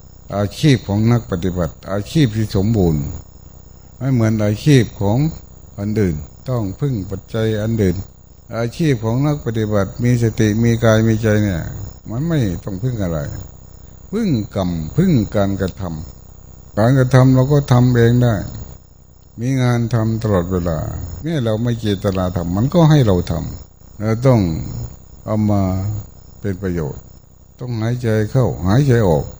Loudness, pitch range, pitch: -17 LUFS, 95-120 Hz, 110 Hz